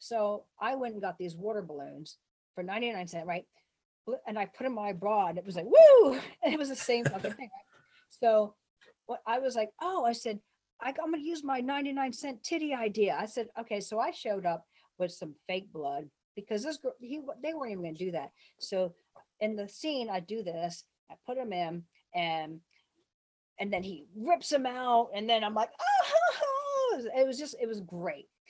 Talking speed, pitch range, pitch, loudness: 205 wpm, 185-270 Hz, 220 Hz, -31 LUFS